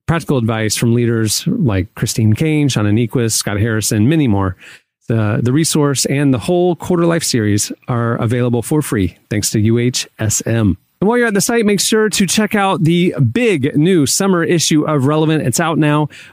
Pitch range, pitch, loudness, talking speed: 115-170 Hz, 140 Hz, -14 LUFS, 185 wpm